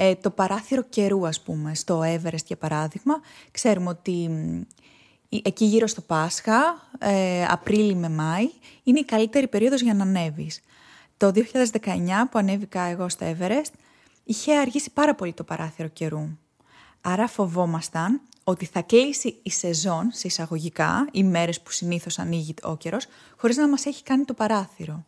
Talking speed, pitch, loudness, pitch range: 155 wpm, 195 Hz, -24 LUFS, 170-235 Hz